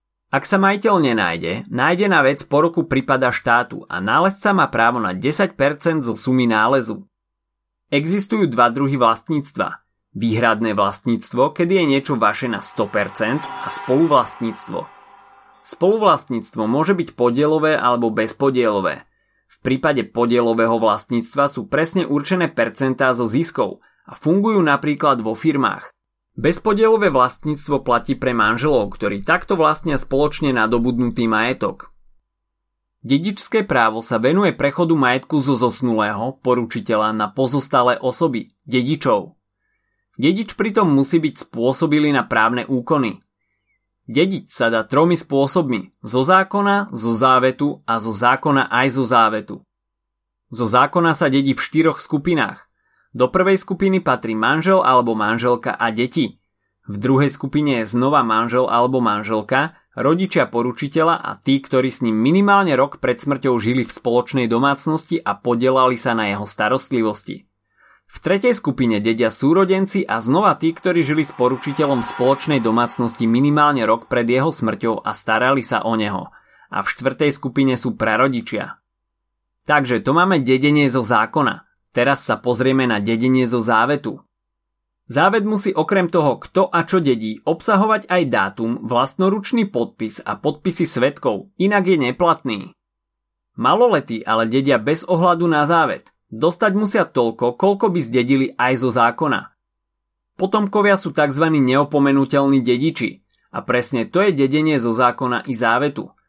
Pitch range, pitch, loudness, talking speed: 115-160 Hz, 130 Hz, -18 LUFS, 135 wpm